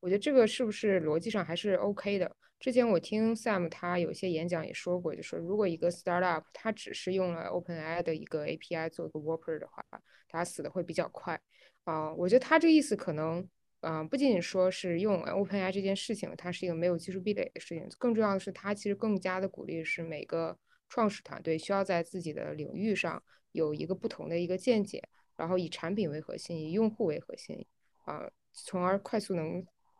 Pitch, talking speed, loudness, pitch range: 185 Hz, 365 characters per minute, -33 LUFS, 170-205 Hz